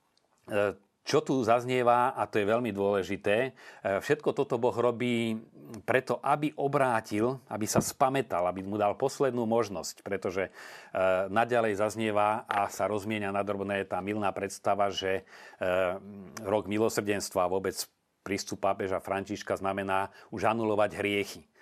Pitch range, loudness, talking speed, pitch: 100-115 Hz, -30 LUFS, 120 wpm, 105 Hz